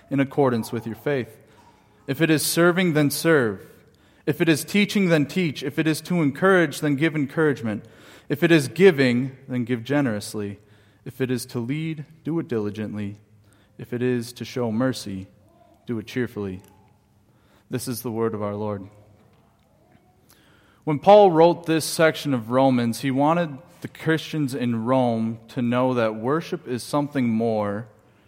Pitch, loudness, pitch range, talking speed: 125 Hz, -22 LUFS, 110-155 Hz, 160 wpm